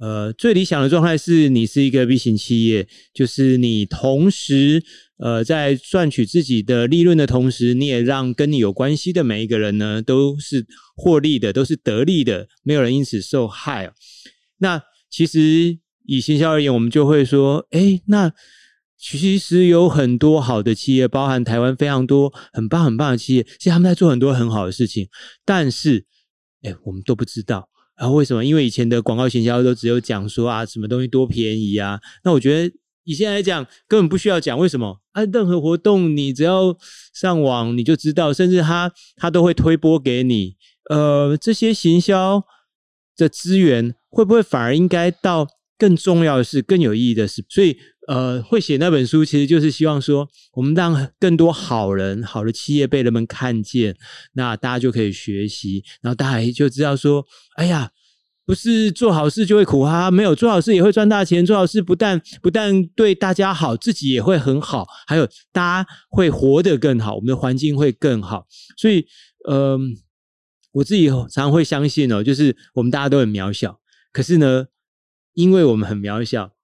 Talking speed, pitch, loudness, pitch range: 280 characters per minute, 140 Hz, -17 LUFS, 120-175 Hz